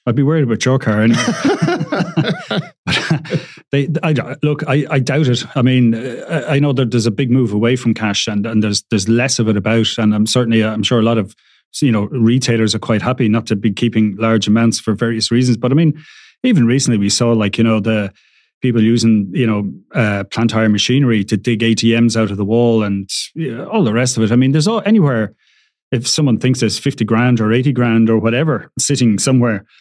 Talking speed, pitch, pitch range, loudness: 220 wpm, 115 Hz, 110-130 Hz, -15 LUFS